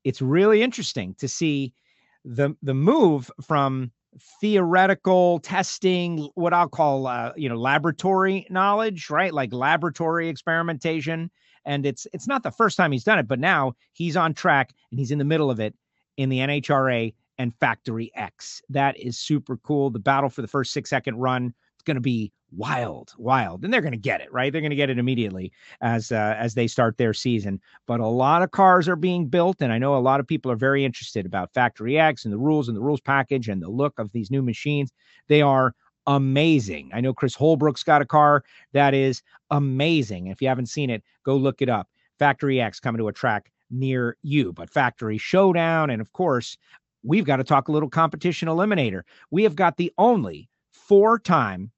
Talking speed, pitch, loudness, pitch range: 205 wpm, 140 Hz, -22 LUFS, 125-165 Hz